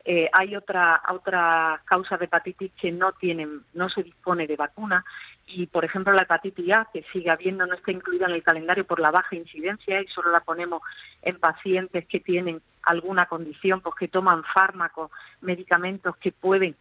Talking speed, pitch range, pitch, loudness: 180 wpm, 170-185 Hz, 180 Hz, -24 LUFS